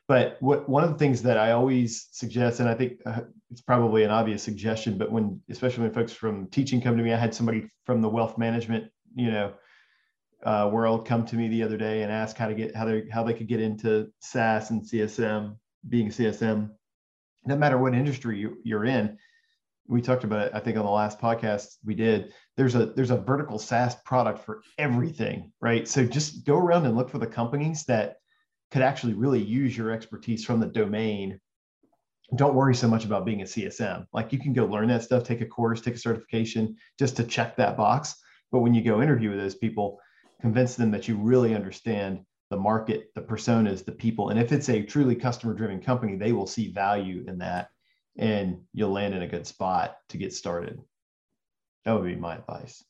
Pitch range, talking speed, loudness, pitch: 110-125 Hz, 210 wpm, -26 LUFS, 115 Hz